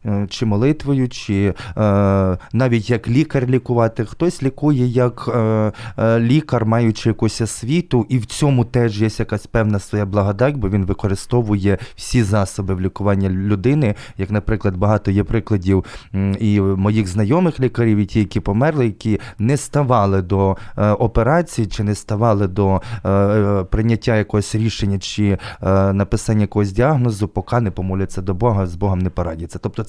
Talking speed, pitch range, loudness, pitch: 155 wpm, 100-120 Hz, -18 LUFS, 110 Hz